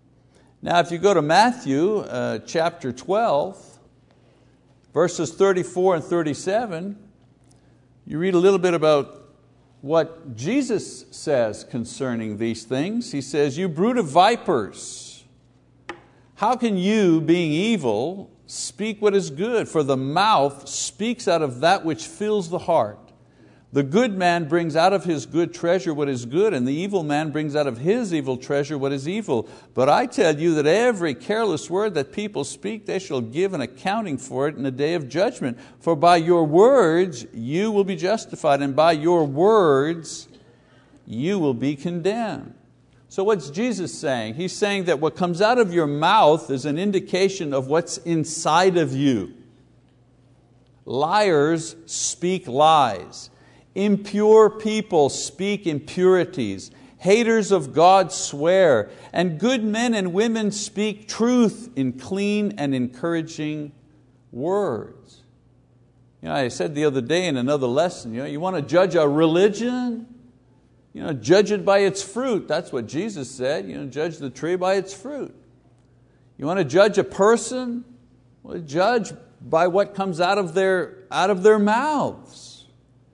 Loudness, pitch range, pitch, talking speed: -21 LUFS, 140-200 Hz, 170 Hz, 155 wpm